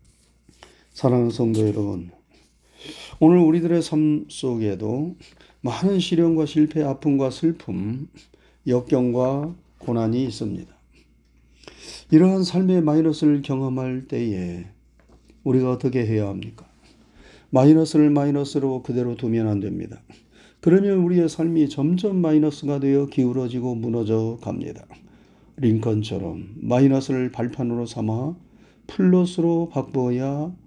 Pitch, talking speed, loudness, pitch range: 130 Hz, 265 characters per minute, -21 LUFS, 115-155 Hz